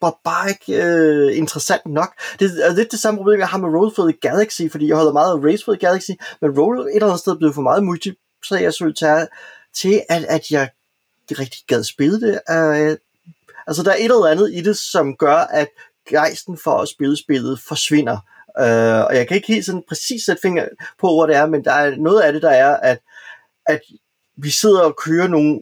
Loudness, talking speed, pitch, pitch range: -16 LUFS, 230 wpm, 165 Hz, 150-195 Hz